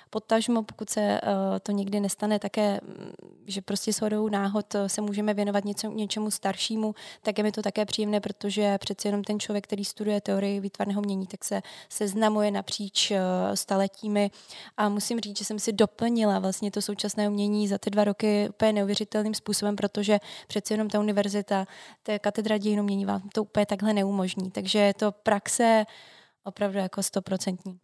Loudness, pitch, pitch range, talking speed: -27 LUFS, 205 Hz, 200-215 Hz, 170 wpm